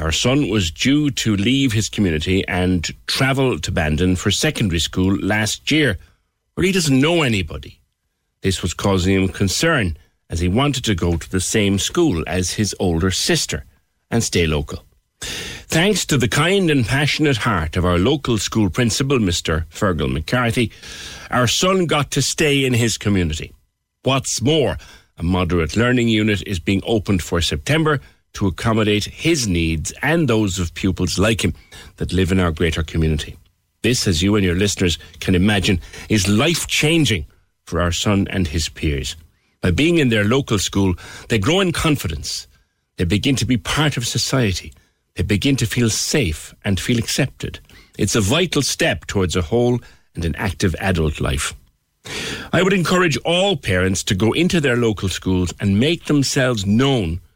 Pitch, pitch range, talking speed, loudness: 100 Hz, 90-125 Hz, 170 wpm, -18 LUFS